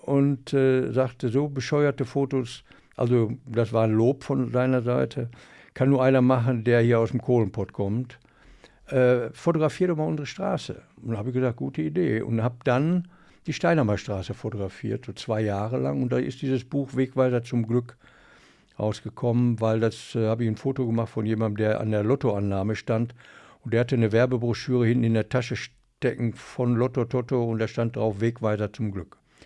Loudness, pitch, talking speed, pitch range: -25 LUFS, 120 Hz, 185 wpm, 110-130 Hz